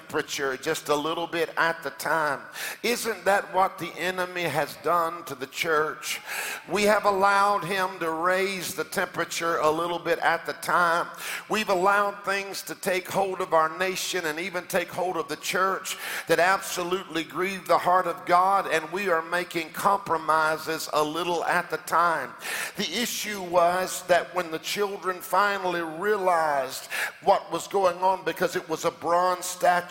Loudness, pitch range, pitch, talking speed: -26 LUFS, 165-185 Hz, 175 Hz, 170 wpm